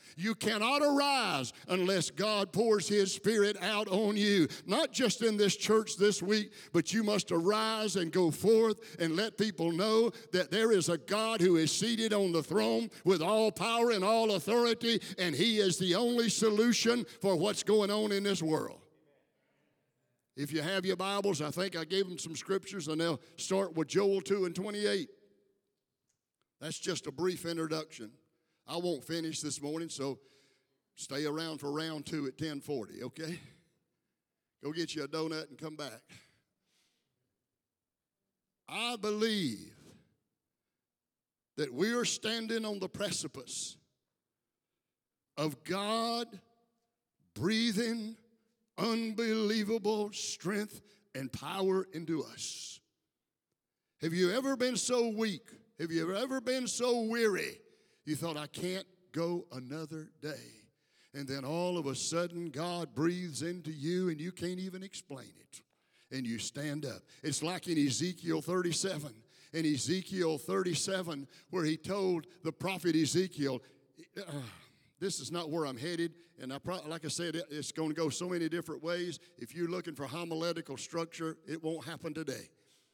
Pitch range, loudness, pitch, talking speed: 160-210 Hz, -33 LUFS, 175 Hz, 150 wpm